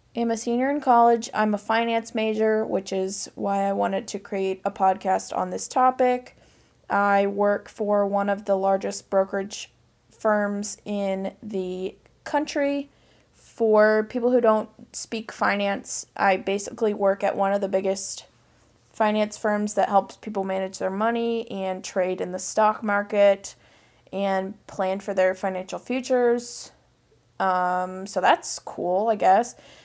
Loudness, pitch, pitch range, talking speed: -24 LUFS, 200 Hz, 190-220 Hz, 145 wpm